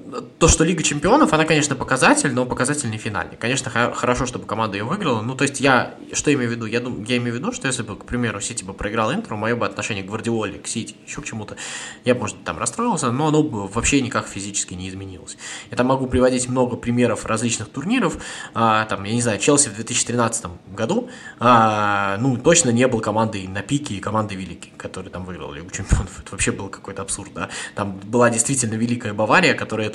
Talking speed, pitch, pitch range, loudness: 220 wpm, 115 Hz, 100-125 Hz, -20 LUFS